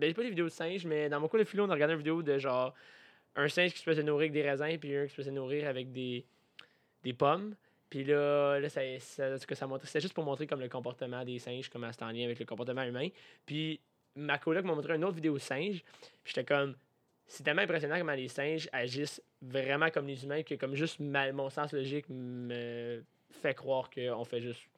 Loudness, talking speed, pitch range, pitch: -35 LUFS, 230 wpm, 130-155 Hz, 140 Hz